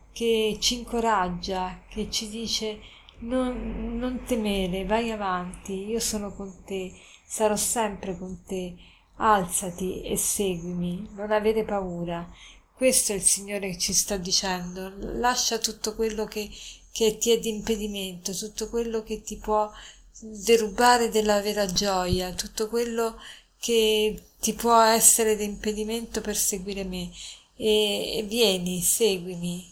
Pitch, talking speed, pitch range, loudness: 215 Hz, 135 wpm, 190-225 Hz, -25 LUFS